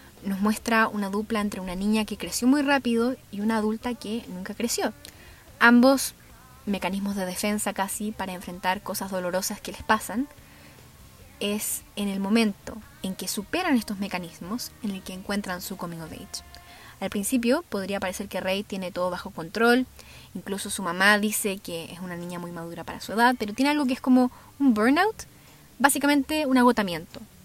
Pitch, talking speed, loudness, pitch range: 210 Hz, 175 wpm, -26 LUFS, 190-235 Hz